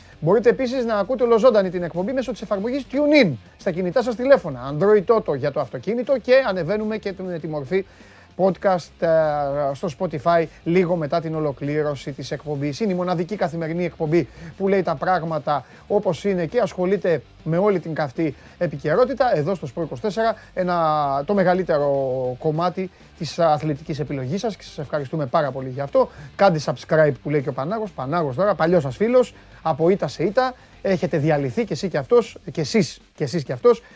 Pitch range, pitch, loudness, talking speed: 150-205 Hz, 175 Hz, -21 LUFS, 180 wpm